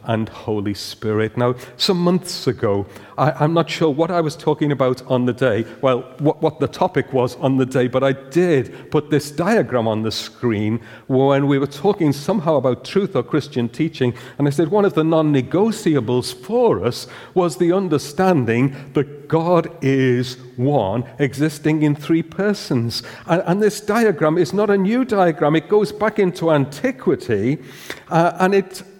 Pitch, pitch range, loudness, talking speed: 150 Hz, 125-175 Hz, -19 LUFS, 175 wpm